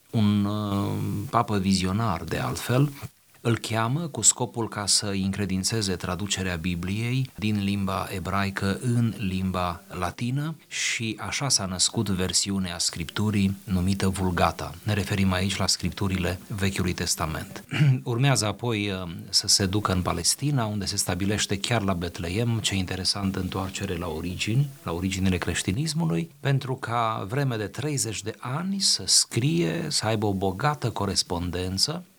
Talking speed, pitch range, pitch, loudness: 130 wpm, 95-120 Hz, 100 Hz, -25 LUFS